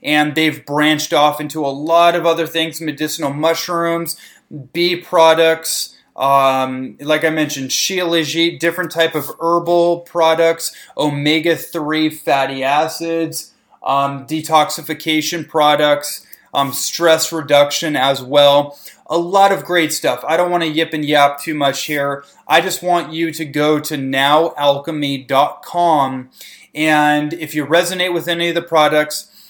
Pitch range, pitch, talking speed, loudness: 145-165 Hz, 155 Hz, 140 wpm, -15 LUFS